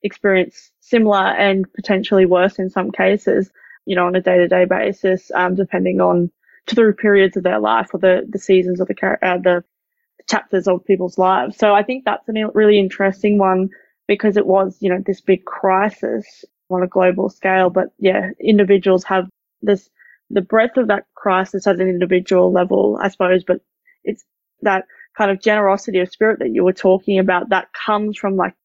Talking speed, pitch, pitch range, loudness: 185 wpm, 190 Hz, 185-205 Hz, -16 LUFS